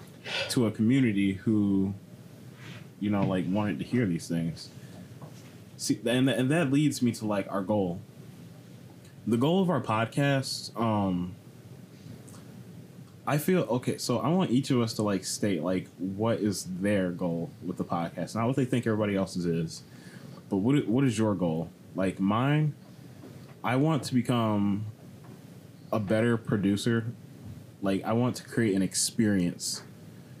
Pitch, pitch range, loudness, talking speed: 110 Hz, 95-130 Hz, -28 LUFS, 150 wpm